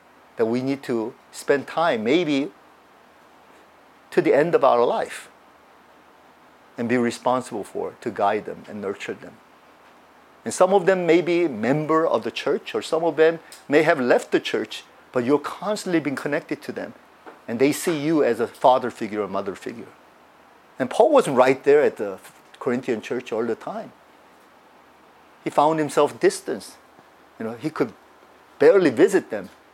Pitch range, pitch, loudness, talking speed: 125-180 Hz, 150 Hz, -22 LUFS, 165 wpm